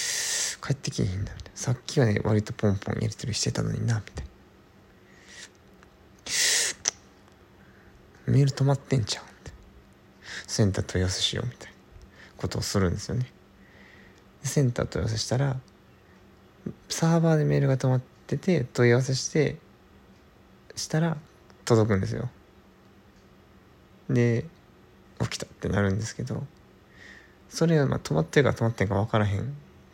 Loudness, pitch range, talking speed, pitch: -26 LUFS, 95-135 Hz, 305 characters per minute, 115 Hz